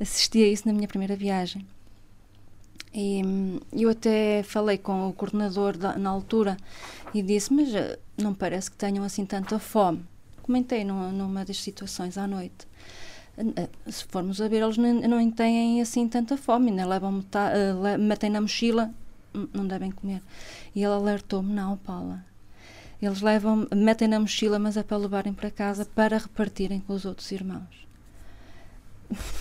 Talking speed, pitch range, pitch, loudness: 155 wpm, 190-215 Hz, 200 Hz, -26 LUFS